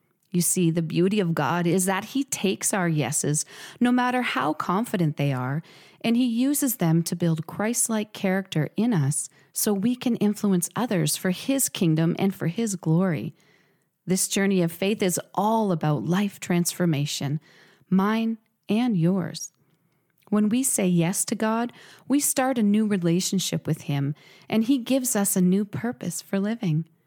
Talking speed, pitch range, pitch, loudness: 165 wpm, 165-215 Hz, 185 Hz, -24 LUFS